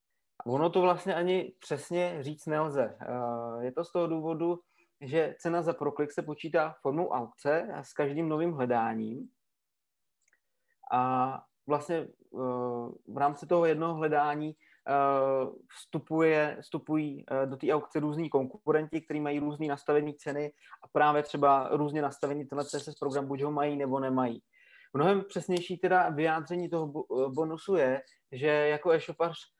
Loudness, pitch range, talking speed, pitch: -31 LUFS, 140-165 Hz, 135 wpm, 150 Hz